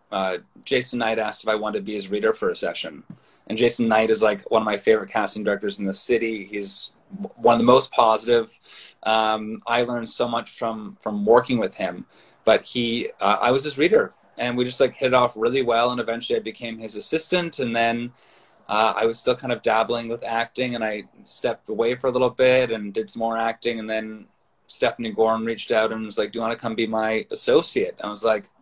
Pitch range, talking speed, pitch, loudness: 110-120 Hz, 235 wpm, 115 Hz, -22 LUFS